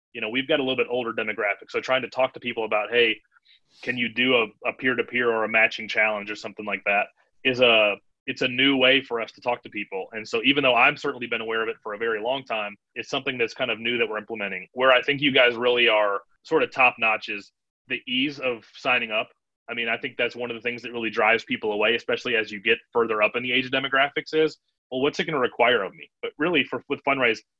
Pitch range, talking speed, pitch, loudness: 110-135 Hz, 265 wpm, 120 Hz, -23 LUFS